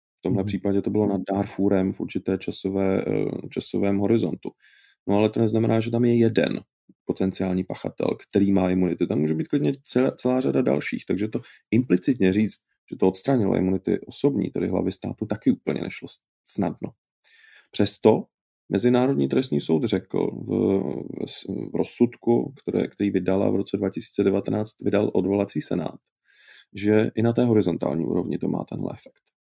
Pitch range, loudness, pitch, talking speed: 95-110 Hz, -24 LUFS, 100 Hz, 155 wpm